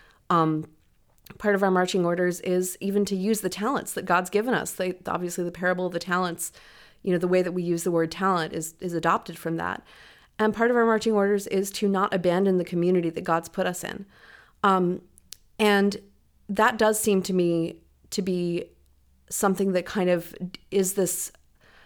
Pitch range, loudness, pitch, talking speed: 175-200 Hz, -25 LUFS, 185 Hz, 190 wpm